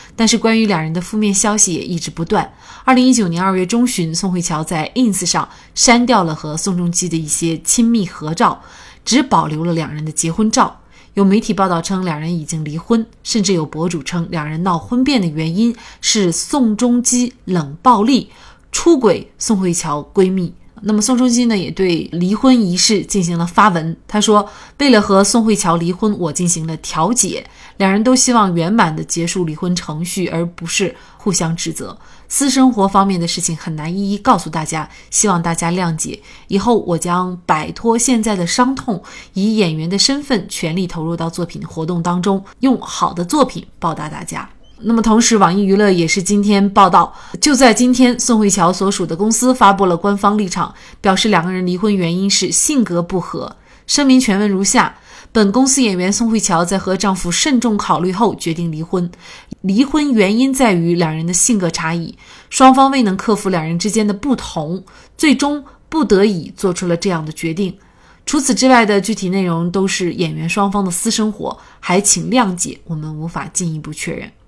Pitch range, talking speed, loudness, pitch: 170-225 Hz, 285 characters per minute, -15 LUFS, 195 Hz